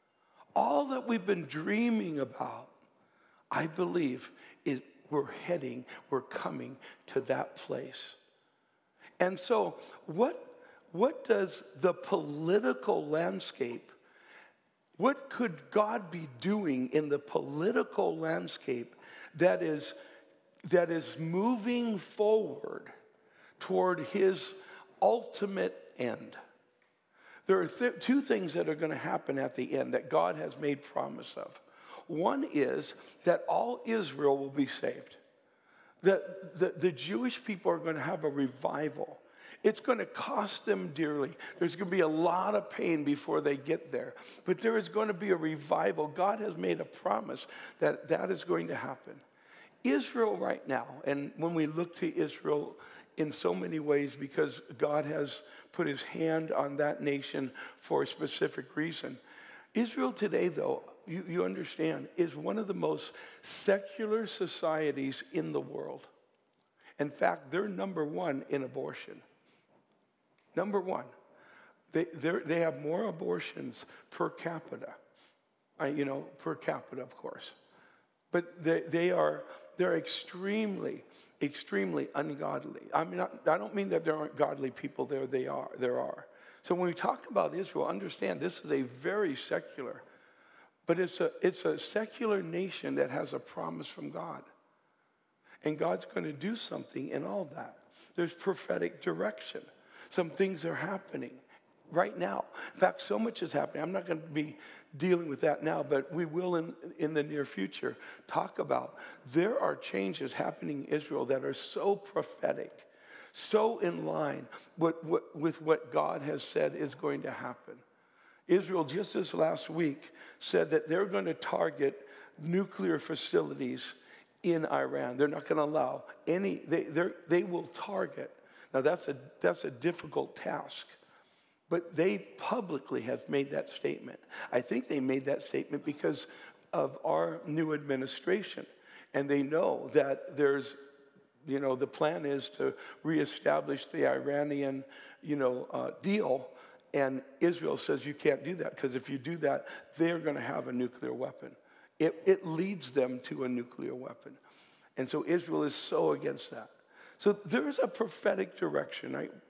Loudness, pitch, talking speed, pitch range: -34 LUFS, 170 Hz, 155 wpm, 145-205 Hz